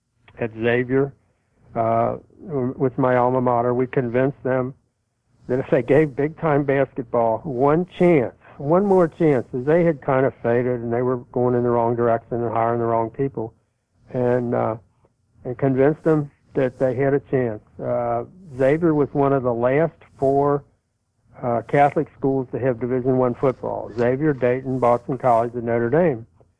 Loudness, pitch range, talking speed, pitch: -21 LUFS, 120-140 Hz, 165 wpm, 125 Hz